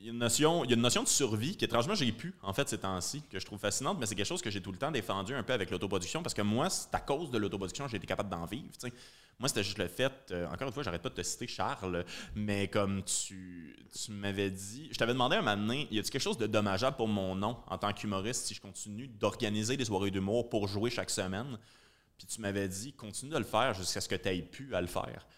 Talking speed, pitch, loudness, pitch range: 285 wpm, 105 Hz, -34 LUFS, 95-120 Hz